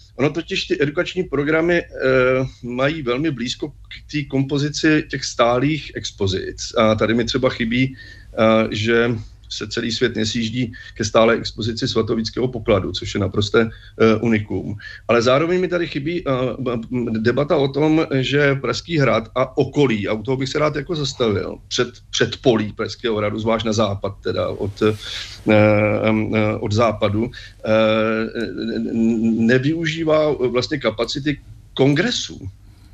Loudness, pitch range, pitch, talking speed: -19 LUFS, 110-140 Hz, 120 Hz, 140 wpm